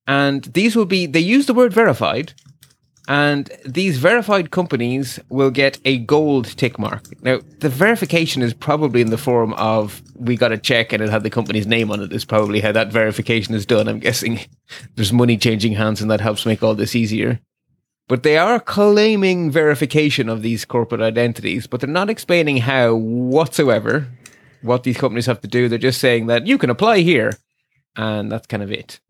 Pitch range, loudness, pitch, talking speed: 115-145 Hz, -17 LUFS, 125 Hz, 195 wpm